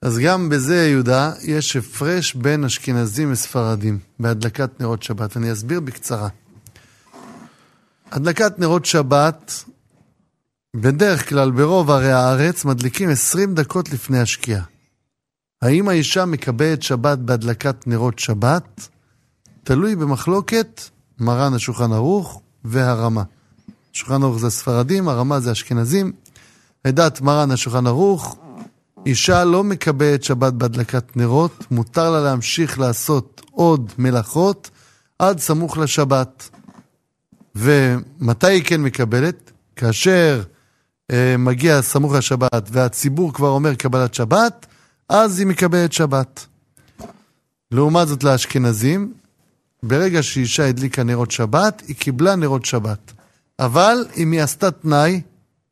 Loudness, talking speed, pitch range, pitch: -17 LUFS, 110 wpm, 125-160 Hz, 140 Hz